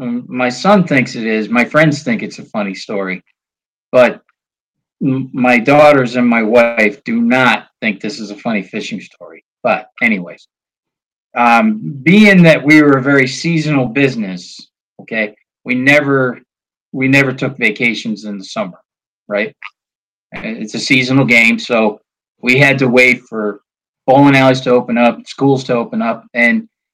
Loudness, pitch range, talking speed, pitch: -12 LUFS, 115-140 Hz, 155 wpm, 125 Hz